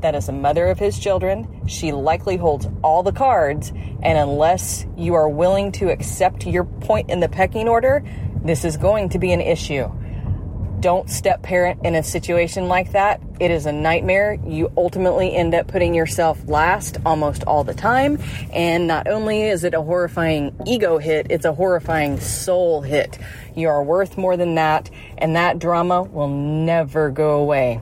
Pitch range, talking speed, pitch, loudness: 150-180 Hz, 180 wpm, 165 Hz, -19 LUFS